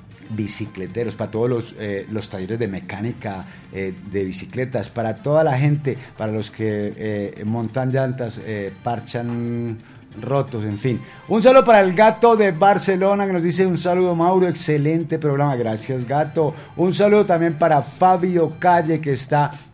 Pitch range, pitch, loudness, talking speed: 110-170 Hz, 130 Hz, -19 LUFS, 160 wpm